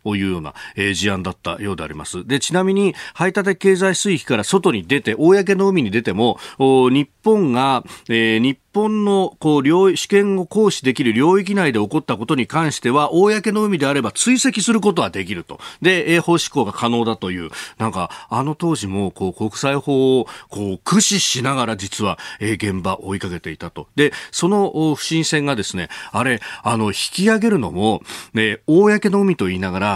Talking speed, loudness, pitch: 345 characters per minute, -18 LUFS, 140 Hz